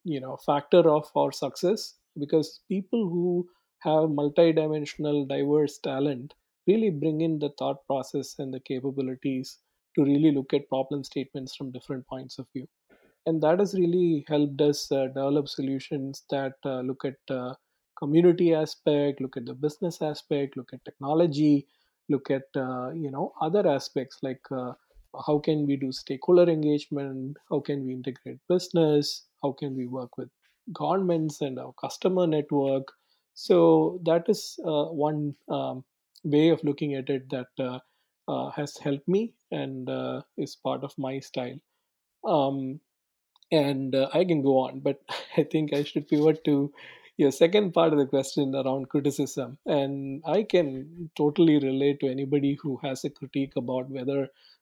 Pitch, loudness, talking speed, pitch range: 145 Hz, -27 LUFS, 160 wpm, 135-155 Hz